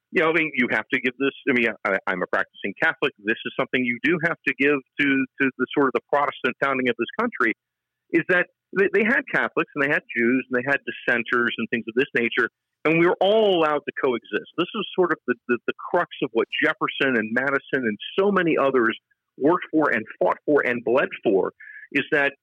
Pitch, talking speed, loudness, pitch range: 140 Hz, 235 wpm, -22 LUFS, 125-160 Hz